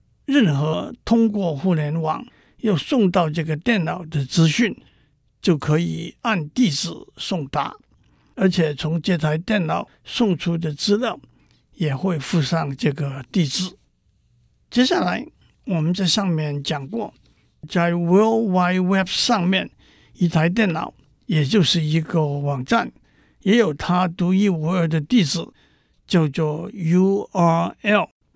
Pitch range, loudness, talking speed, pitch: 160-200 Hz, -21 LUFS, 205 characters per minute, 175 Hz